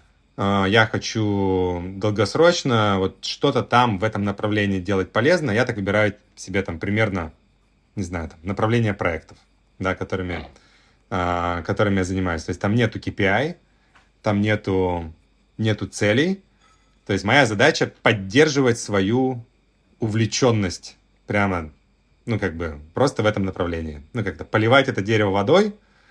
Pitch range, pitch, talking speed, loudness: 95-115 Hz, 100 Hz, 135 wpm, -21 LUFS